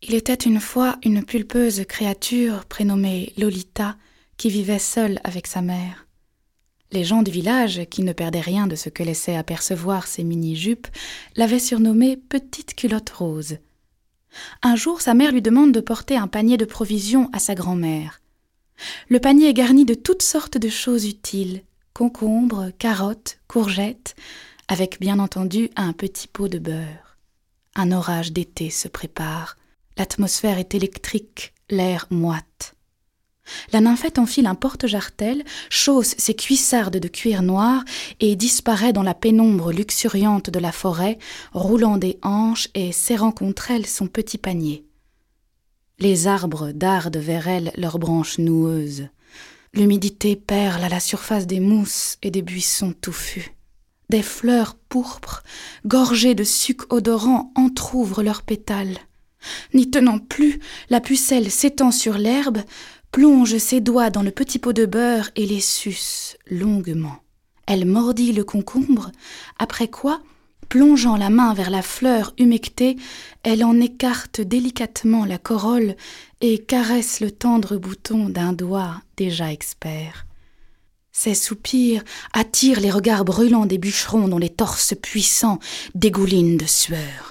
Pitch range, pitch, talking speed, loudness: 185-240 Hz, 210 Hz, 140 wpm, -19 LUFS